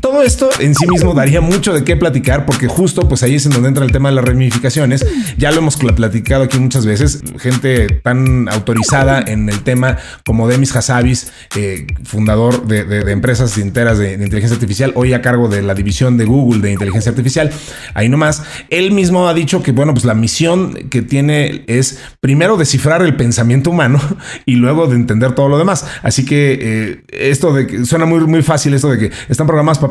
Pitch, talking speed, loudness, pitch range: 130 Hz, 205 wpm, -12 LUFS, 120-150 Hz